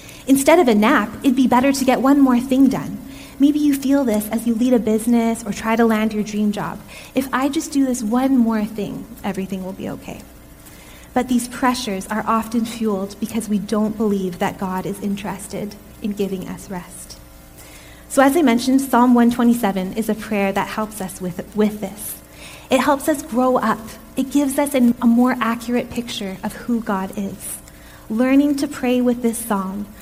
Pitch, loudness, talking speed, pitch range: 225 Hz, -19 LUFS, 195 wpm, 200-255 Hz